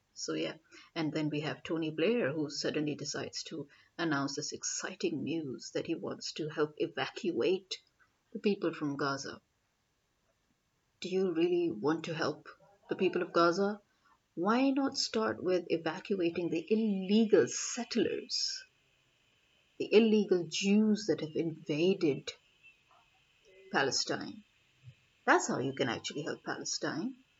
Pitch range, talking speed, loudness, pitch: 150-220 Hz, 125 wpm, -33 LUFS, 180 Hz